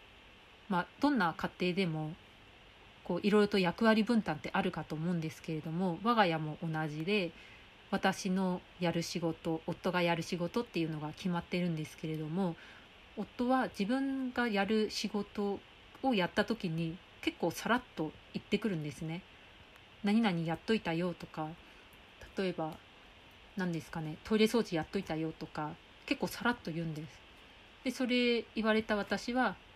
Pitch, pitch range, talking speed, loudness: 180 Hz, 160-215 Hz, 305 characters per minute, -35 LUFS